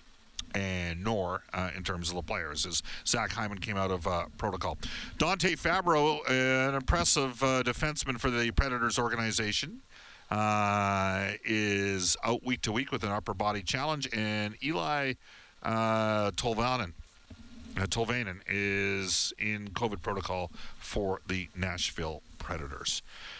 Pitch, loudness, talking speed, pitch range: 105 Hz, -31 LUFS, 130 wpm, 95-125 Hz